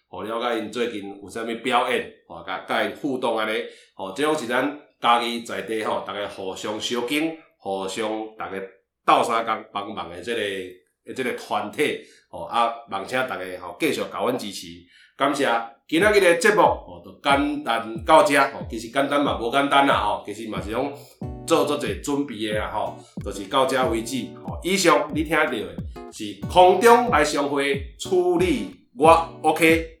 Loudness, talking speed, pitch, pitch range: -22 LUFS, 260 characters per minute, 120 Hz, 105-145 Hz